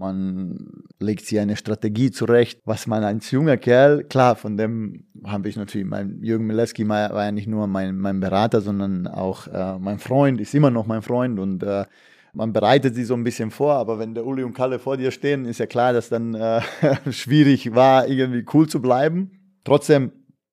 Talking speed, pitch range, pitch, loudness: 200 wpm, 105-130 Hz, 115 Hz, -21 LUFS